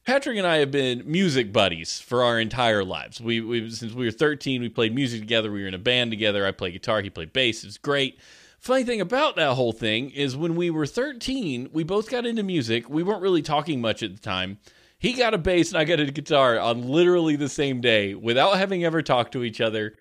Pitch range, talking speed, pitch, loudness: 115-170 Hz, 240 wpm, 130 Hz, -23 LUFS